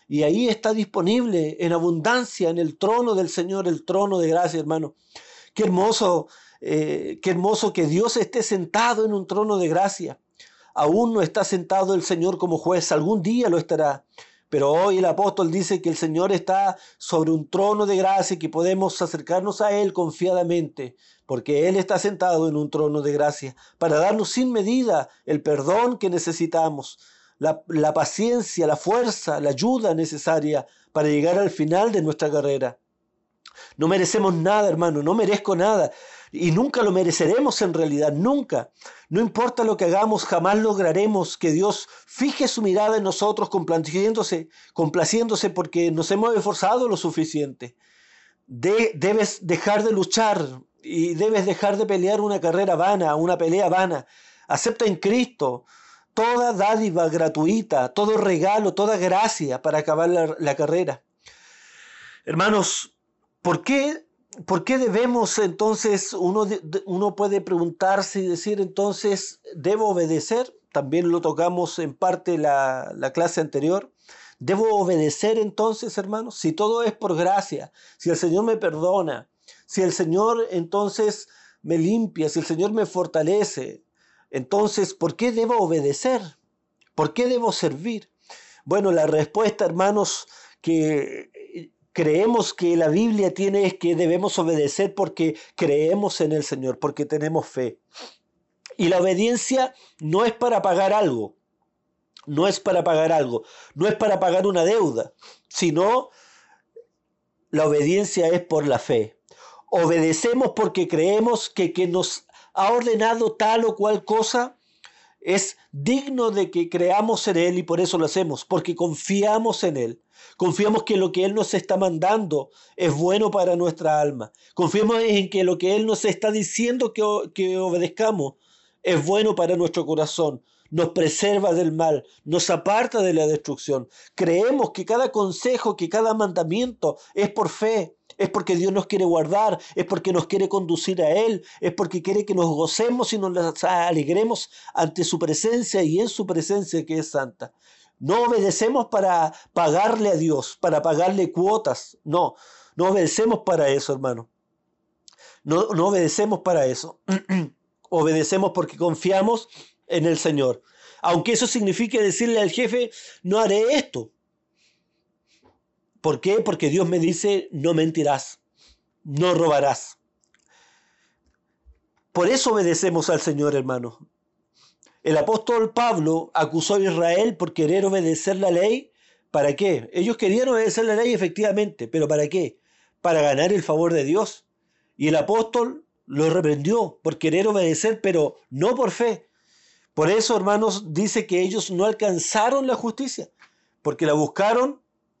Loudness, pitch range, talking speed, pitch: -22 LUFS, 165-215 Hz, 150 wpm, 190 Hz